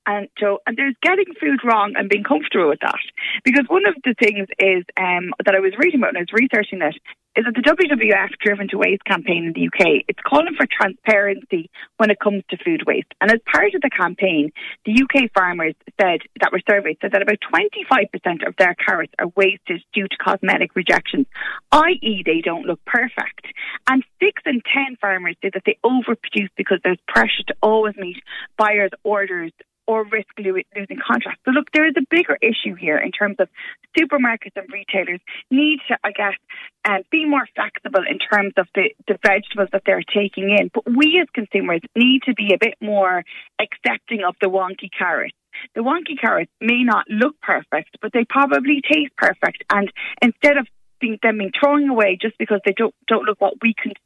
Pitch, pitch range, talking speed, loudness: 220 Hz, 195-280 Hz, 200 wpm, -18 LUFS